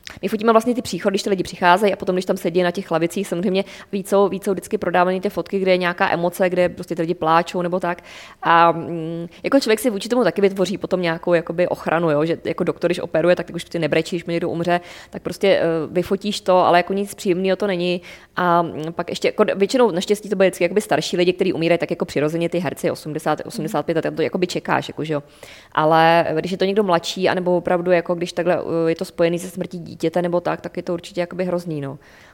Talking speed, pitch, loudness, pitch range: 235 wpm, 180 Hz, -20 LUFS, 170-190 Hz